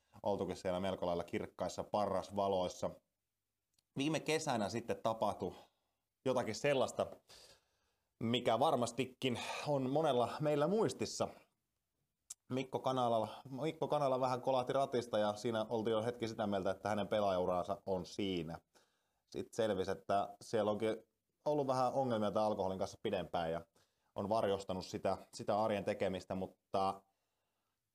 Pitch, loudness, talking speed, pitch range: 110 Hz, -38 LUFS, 120 wpm, 95-125 Hz